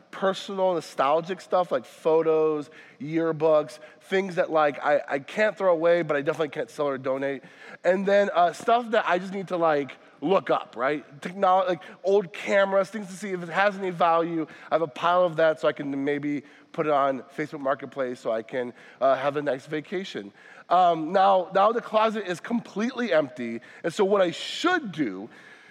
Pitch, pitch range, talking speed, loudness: 170 Hz, 150-195 Hz, 195 wpm, -25 LUFS